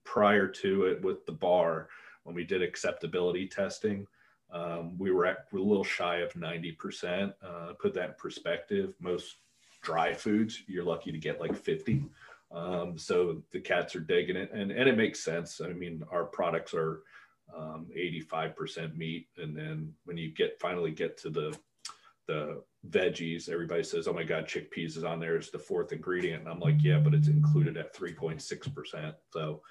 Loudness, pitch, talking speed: -32 LUFS, 100 Hz, 190 wpm